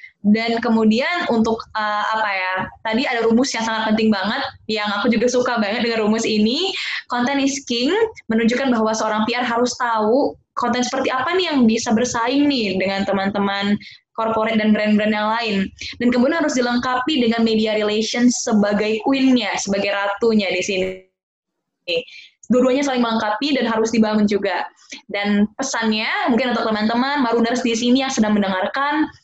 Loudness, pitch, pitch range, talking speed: -19 LUFS, 230 Hz, 215-250 Hz, 155 wpm